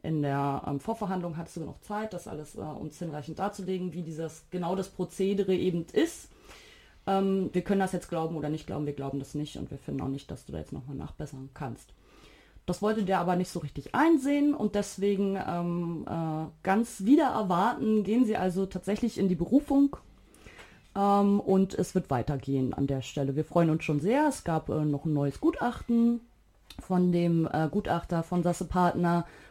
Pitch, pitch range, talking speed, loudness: 180 Hz, 155-200 Hz, 195 wpm, -29 LUFS